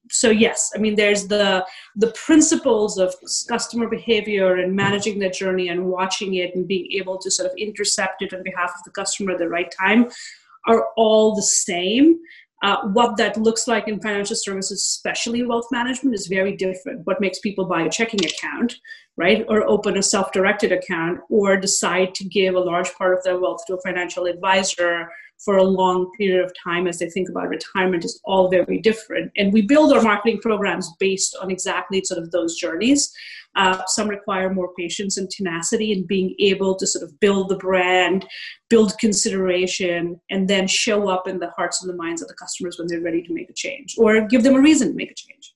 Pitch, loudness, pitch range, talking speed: 195 Hz, -20 LUFS, 185-220 Hz, 205 wpm